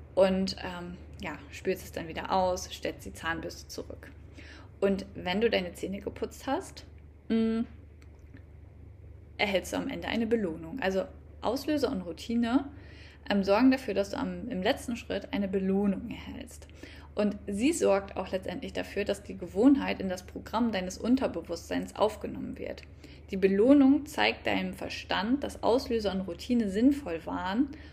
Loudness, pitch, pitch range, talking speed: -30 LUFS, 195 Hz, 165-235 Hz, 150 wpm